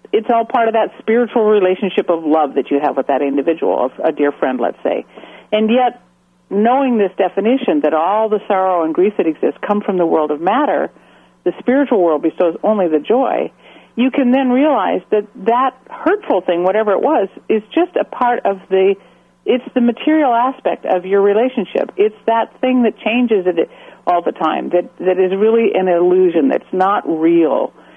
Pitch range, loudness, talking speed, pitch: 175-245 Hz, -15 LUFS, 190 wpm, 210 Hz